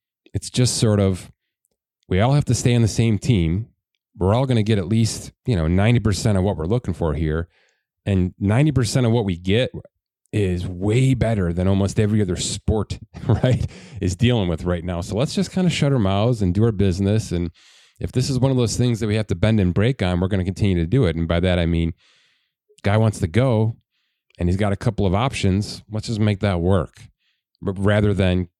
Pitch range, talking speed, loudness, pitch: 95-115 Hz, 225 wpm, -20 LUFS, 105 Hz